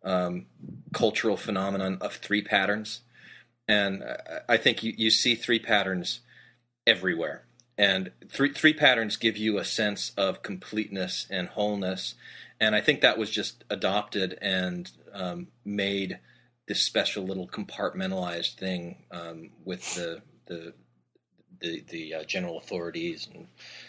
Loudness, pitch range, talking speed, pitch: -27 LUFS, 90-110 Hz, 130 wpm, 100 Hz